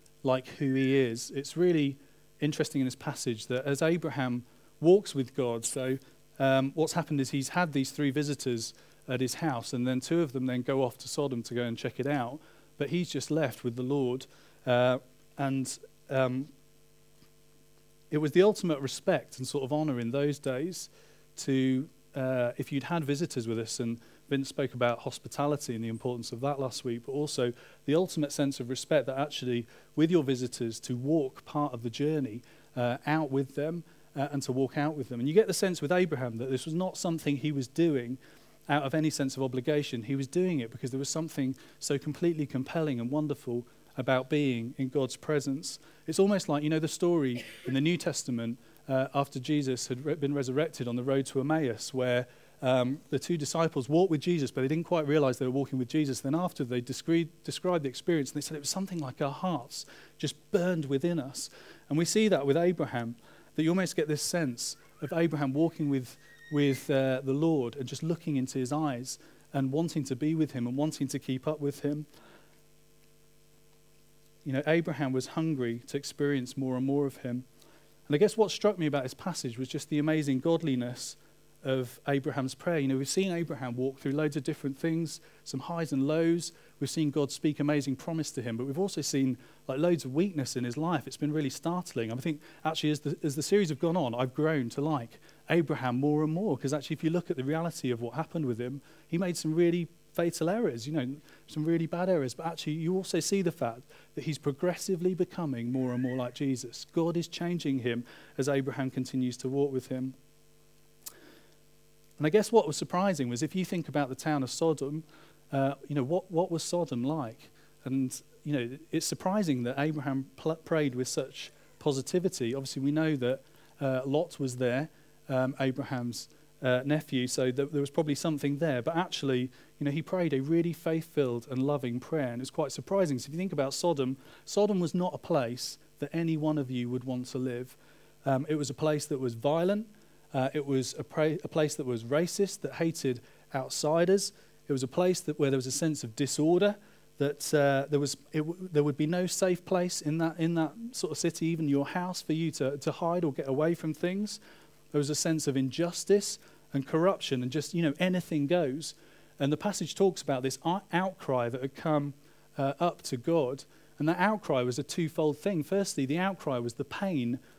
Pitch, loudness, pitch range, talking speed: 150 Hz, -31 LUFS, 135-160 Hz, 210 wpm